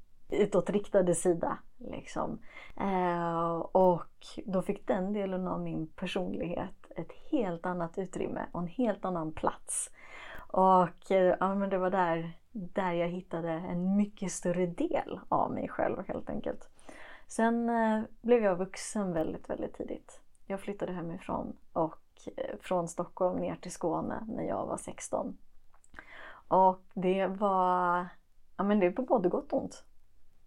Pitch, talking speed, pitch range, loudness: 185 Hz, 140 wpm, 175-200 Hz, -32 LUFS